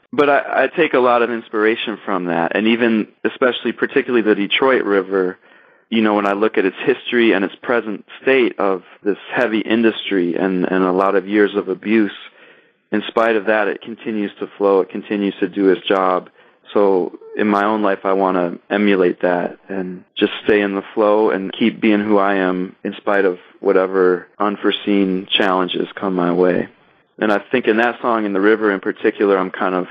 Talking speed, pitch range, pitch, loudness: 200 wpm, 95-110 Hz, 100 Hz, -17 LUFS